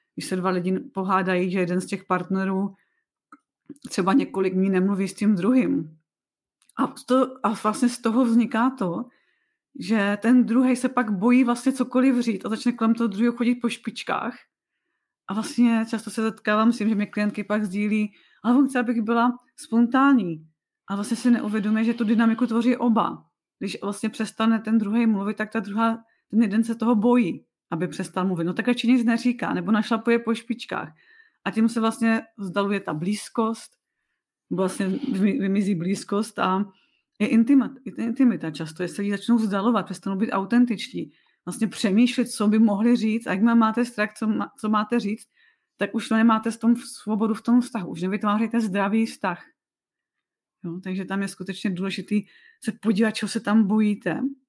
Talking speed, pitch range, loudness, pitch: 170 wpm, 200-240 Hz, -23 LUFS, 225 Hz